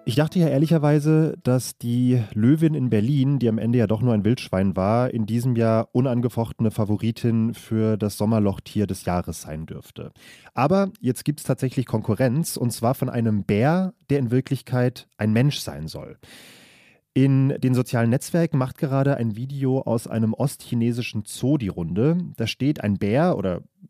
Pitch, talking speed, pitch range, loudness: 125 Hz, 170 wpm, 110-140 Hz, -22 LUFS